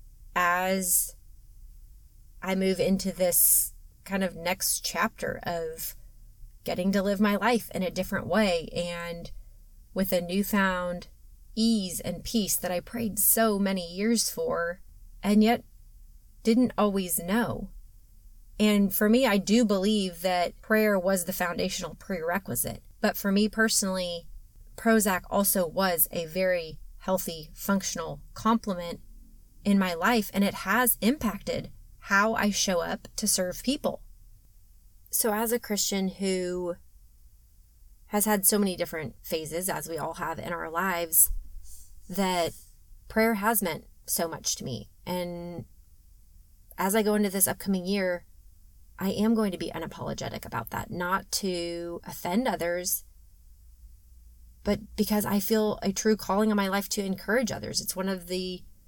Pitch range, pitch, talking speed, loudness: 170-205 Hz, 185 Hz, 140 wpm, -27 LUFS